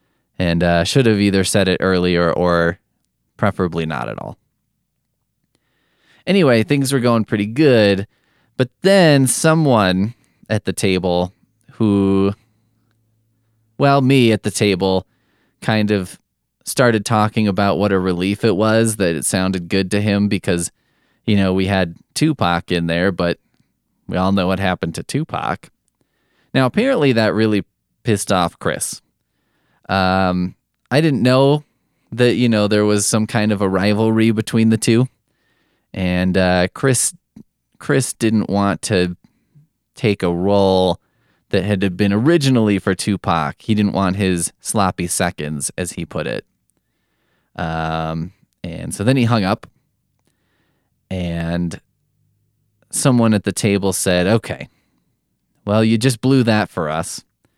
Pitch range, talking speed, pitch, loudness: 95-115 Hz, 140 wpm, 105 Hz, -17 LUFS